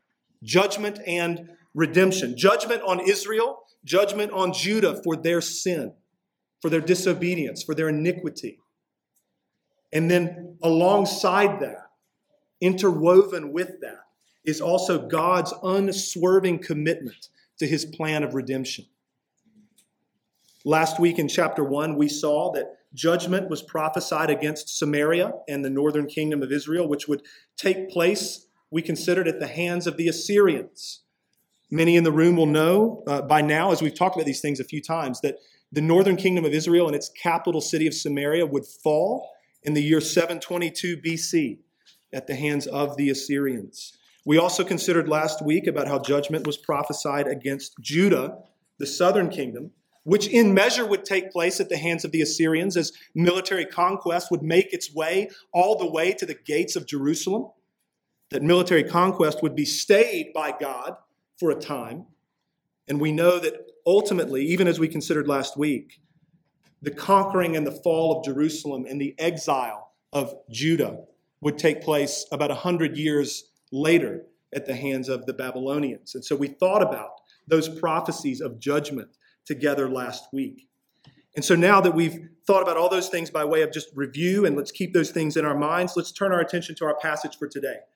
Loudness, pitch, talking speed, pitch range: -23 LUFS, 165 Hz, 165 wpm, 150-180 Hz